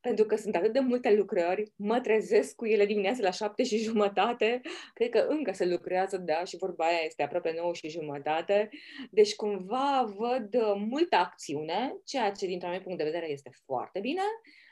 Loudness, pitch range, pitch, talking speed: -29 LUFS, 185-250 Hz, 215 Hz, 185 wpm